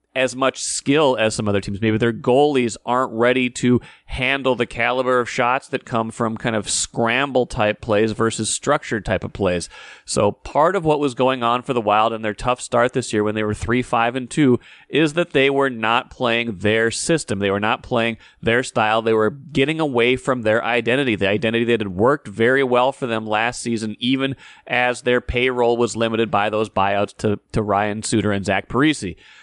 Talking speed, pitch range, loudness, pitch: 210 wpm, 110-130 Hz, -19 LUFS, 115 Hz